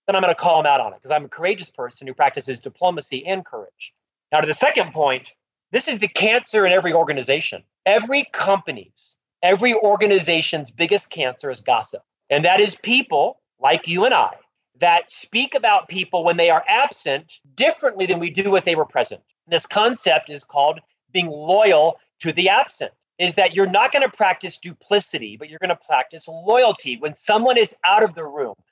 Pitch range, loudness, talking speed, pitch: 155-210 Hz, -19 LUFS, 190 wpm, 180 Hz